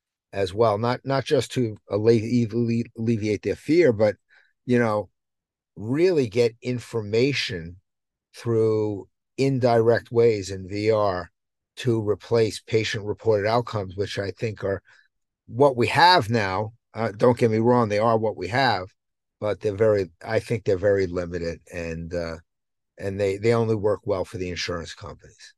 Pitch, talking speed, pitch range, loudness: 110 Hz, 150 wpm, 100-120 Hz, -23 LUFS